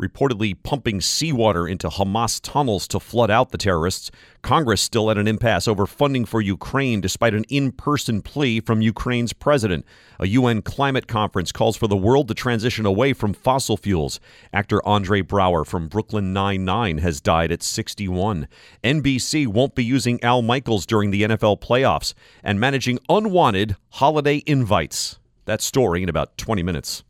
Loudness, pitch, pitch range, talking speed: -20 LUFS, 110 Hz, 100-130 Hz, 160 wpm